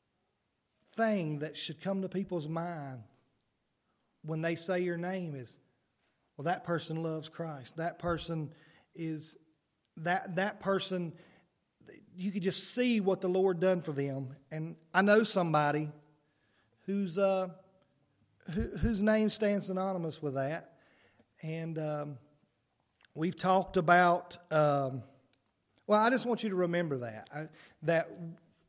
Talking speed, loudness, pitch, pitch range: 130 wpm, -33 LUFS, 165 Hz, 150-185 Hz